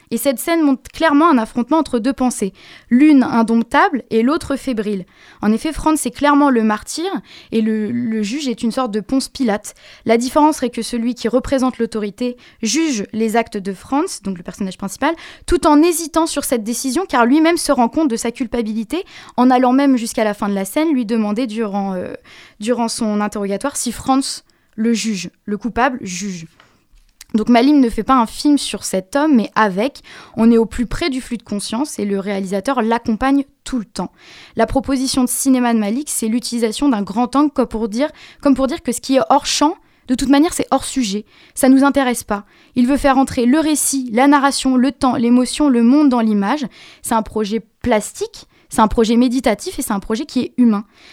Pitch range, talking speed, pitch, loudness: 225-275 Hz, 210 wpm, 245 Hz, -17 LUFS